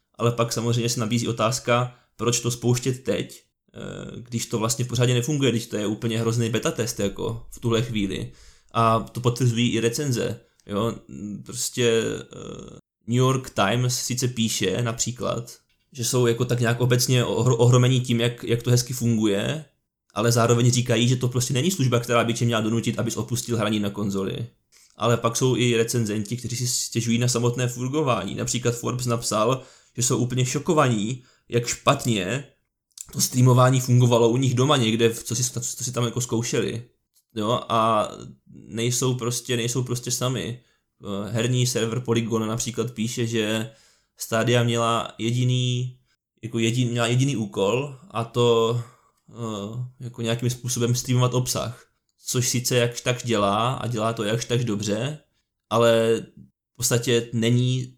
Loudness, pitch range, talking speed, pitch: -23 LUFS, 115-125 Hz, 150 wpm, 120 Hz